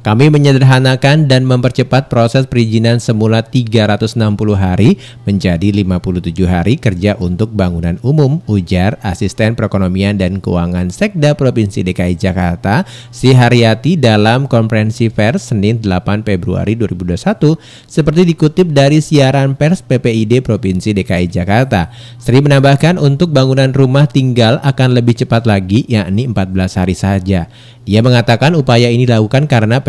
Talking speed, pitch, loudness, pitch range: 125 wpm, 115 Hz, -11 LUFS, 100-130 Hz